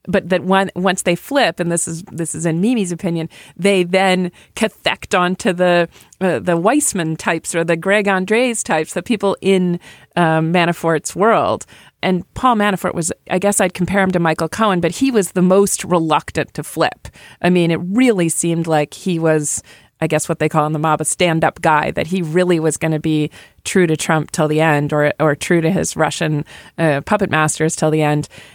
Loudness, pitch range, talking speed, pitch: -16 LUFS, 155-190 Hz, 210 wpm, 170 Hz